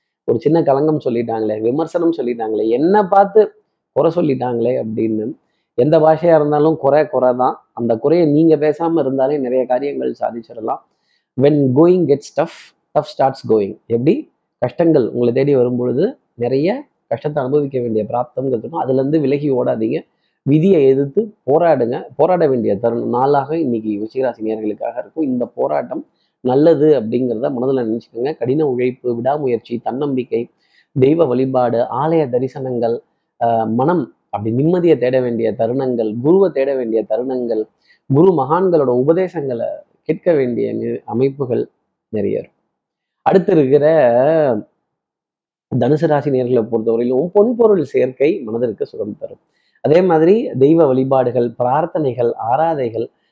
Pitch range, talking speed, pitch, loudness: 120-155 Hz, 115 wpm, 130 Hz, -16 LUFS